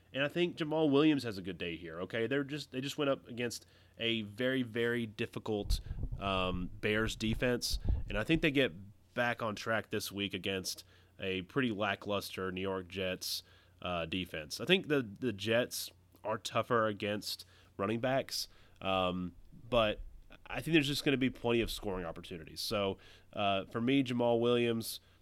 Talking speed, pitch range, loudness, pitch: 175 wpm, 95-120 Hz, -35 LUFS, 105 Hz